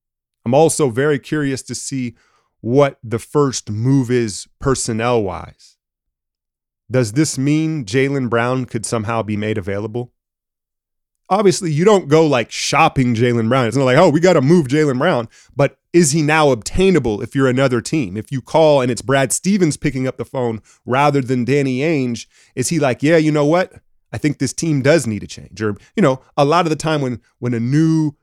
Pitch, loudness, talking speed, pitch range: 135 Hz, -16 LUFS, 195 wpm, 120-155 Hz